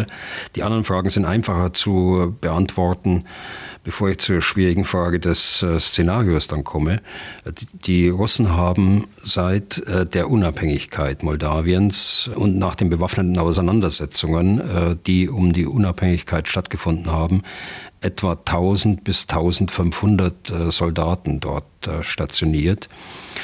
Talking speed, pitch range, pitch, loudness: 105 wpm, 85-100 Hz, 90 Hz, -19 LUFS